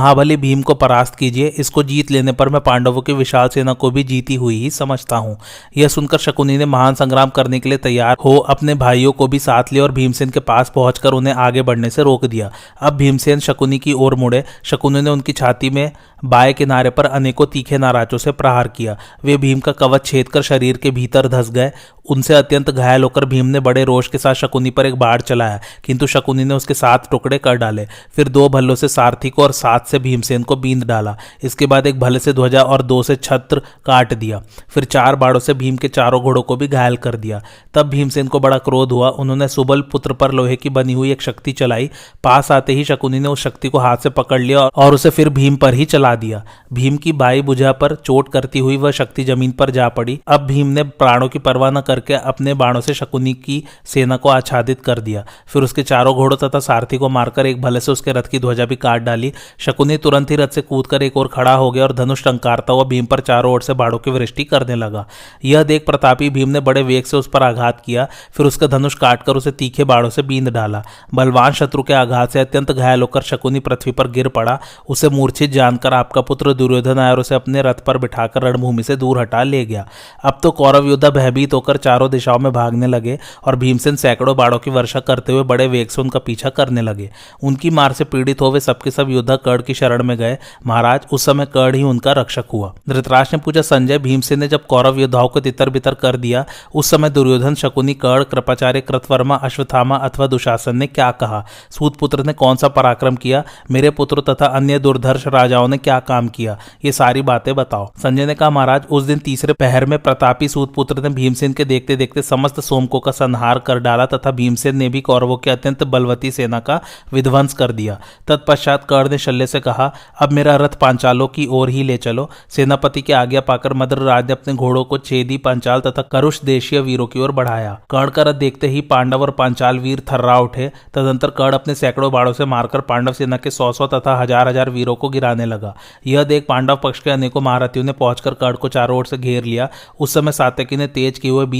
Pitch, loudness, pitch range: 135 Hz, -14 LUFS, 125-140 Hz